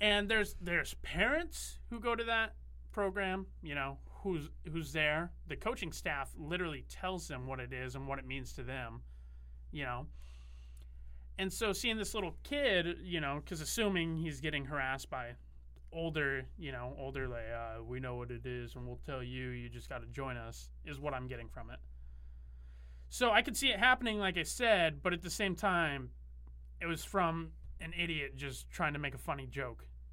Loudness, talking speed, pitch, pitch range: -37 LUFS, 195 wpm, 140 Hz, 115-175 Hz